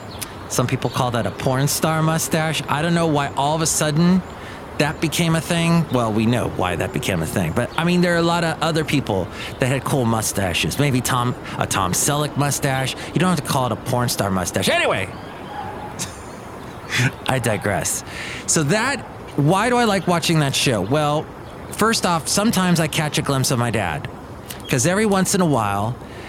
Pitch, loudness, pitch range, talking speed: 145 Hz, -20 LUFS, 125-165 Hz, 200 wpm